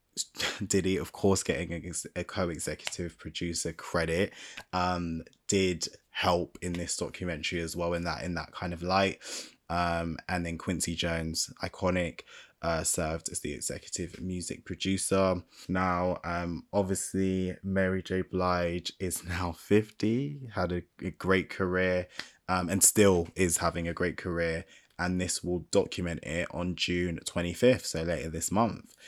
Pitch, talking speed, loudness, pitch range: 90 Hz, 145 wpm, -31 LUFS, 85-95 Hz